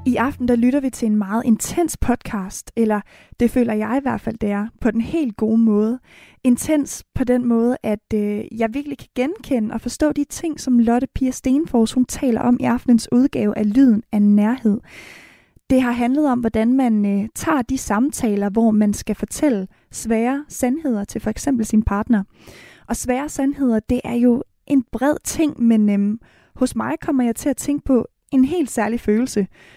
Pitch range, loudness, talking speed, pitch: 220-265 Hz, -19 LUFS, 190 wpm, 240 Hz